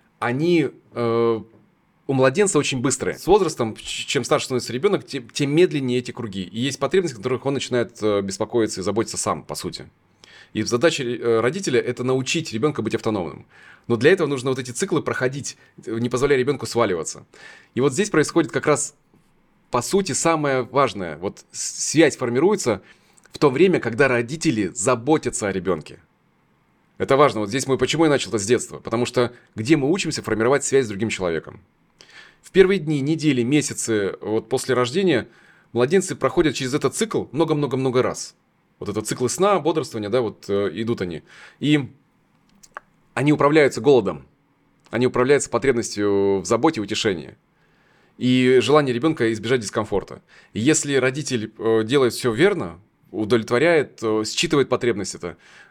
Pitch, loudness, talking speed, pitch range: 130 Hz, -21 LUFS, 155 wpm, 115-150 Hz